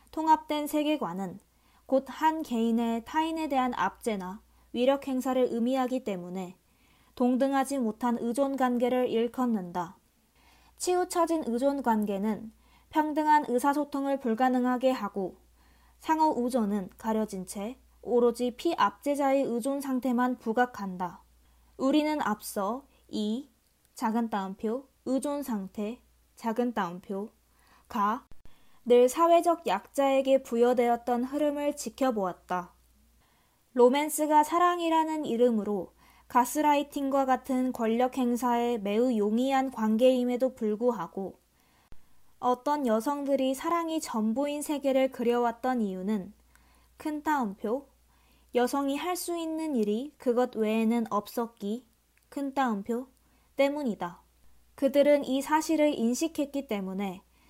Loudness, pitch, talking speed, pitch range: -29 LUFS, 250 Hz, 255 characters per minute, 220-280 Hz